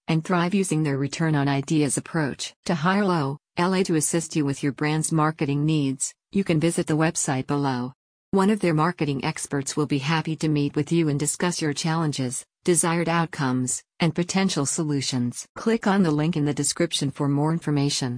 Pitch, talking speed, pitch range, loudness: 155 Hz, 185 wpm, 145-170 Hz, -24 LUFS